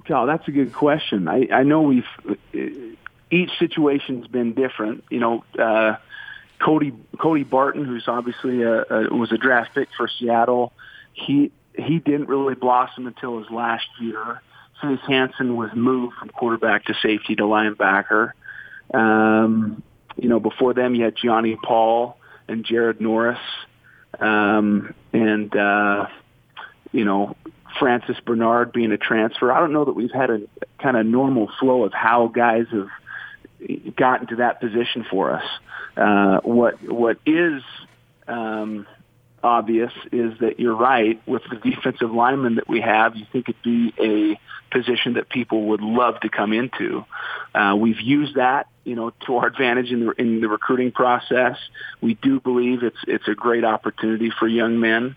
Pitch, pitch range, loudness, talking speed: 120 Hz, 110-130 Hz, -20 LUFS, 160 wpm